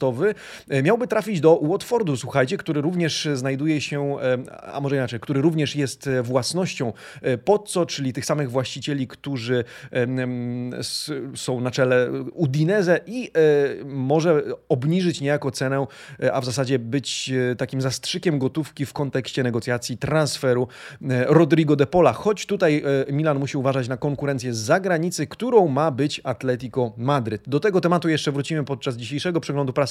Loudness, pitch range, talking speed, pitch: -22 LUFS, 130-155 Hz, 135 wpm, 140 Hz